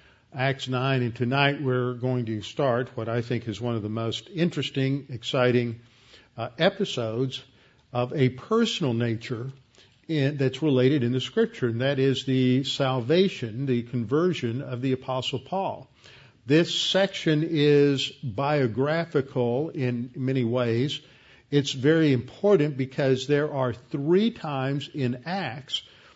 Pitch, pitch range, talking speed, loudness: 130 Hz, 125-145 Hz, 135 wpm, -25 LUFS